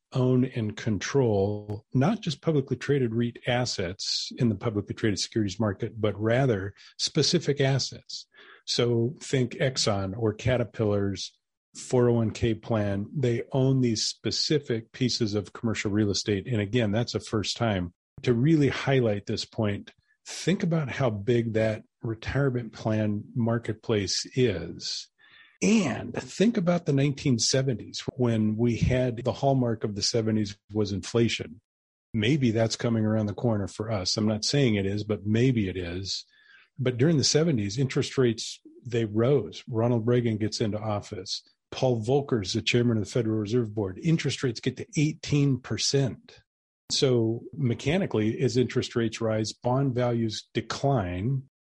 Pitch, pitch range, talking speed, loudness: 120 Hz, 110-130 Hz, 145 wpm, -27 LUFS